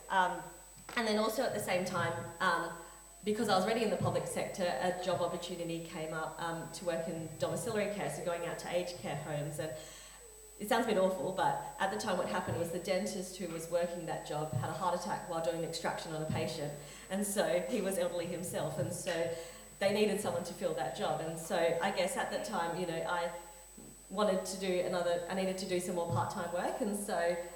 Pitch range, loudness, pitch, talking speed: 165-185 Hz, -36 LUFS, 175 Hz, 225 wpm